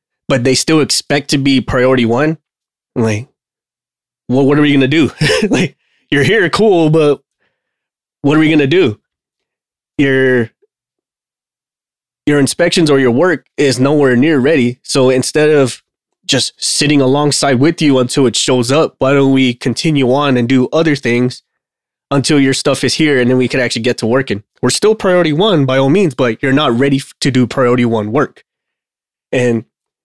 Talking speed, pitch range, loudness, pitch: 170 wpm, 125-150 Hz, -12 LUFS, 135 Hz